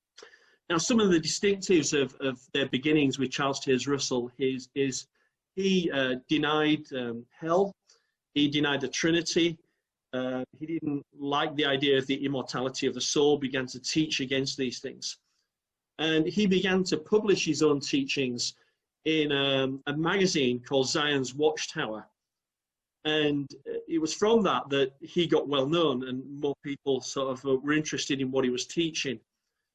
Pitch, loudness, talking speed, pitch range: 145 Hz, -28 LUFS, 160 wpm, 130-160 Hz